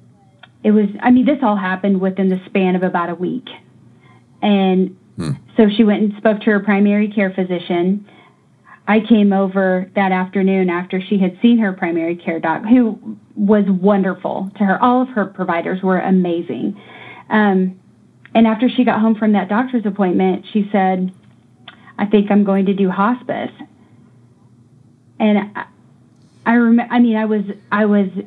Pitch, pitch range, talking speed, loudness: 200 Hz, 185-215 Hz, 165 wpm, -16 LUFS